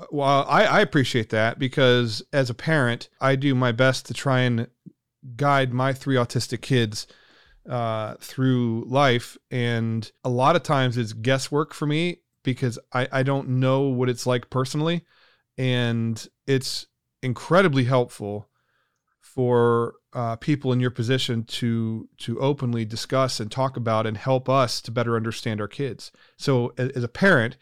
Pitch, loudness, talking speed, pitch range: 125 Hz, -23 LUFS, 155 wpm, 120-135 Hz